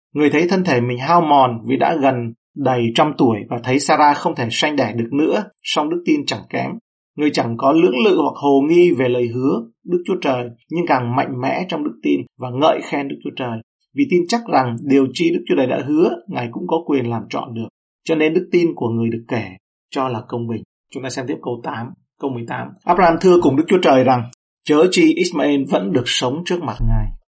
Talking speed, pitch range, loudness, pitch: 235 wpm, 120-170 Hz, -17 LUFS, 140 Hz